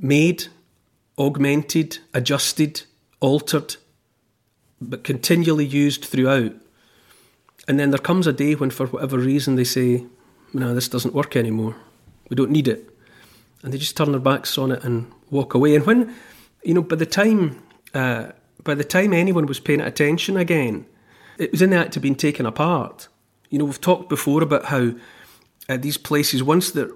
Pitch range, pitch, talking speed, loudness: 125-155 Hz, 140 Hz, 170 wpm, -20 LUFS